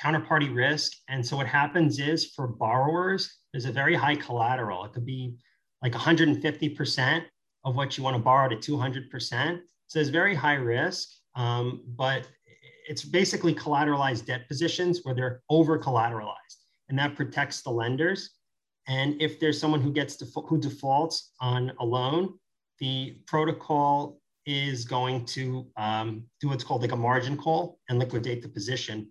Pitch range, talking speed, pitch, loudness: 125-155 Hz, 160 wpm, 140 Hz, -27 LUFS